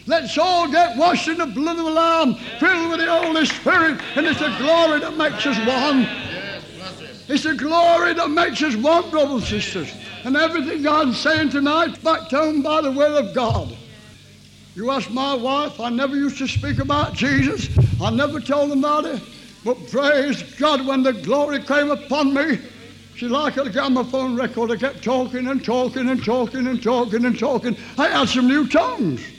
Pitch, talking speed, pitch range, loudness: 280 Hz, 190 wpm, 255-315 Hz, -19 LUFS